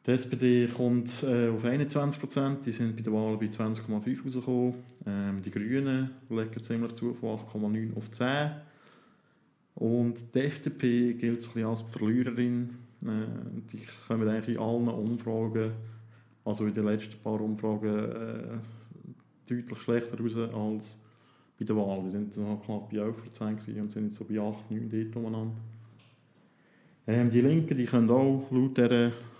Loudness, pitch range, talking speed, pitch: -31 LUFS, 110-125 Hz, 145 wpm, 115 Hz